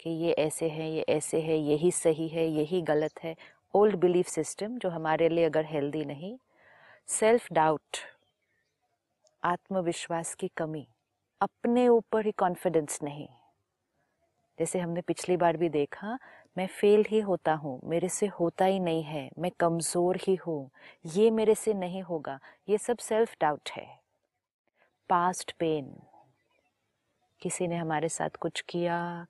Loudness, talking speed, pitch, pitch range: -29 LUFS, 145 wpm, 170 Hz, 160-190 Hz